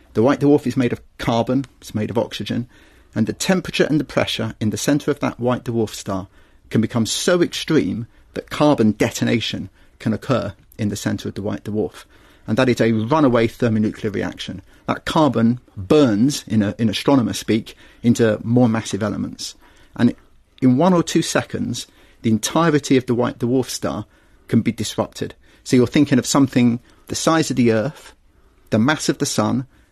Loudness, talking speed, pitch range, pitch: -19 LUFS, 185 wpm, 110-135 Hz, 120 Hz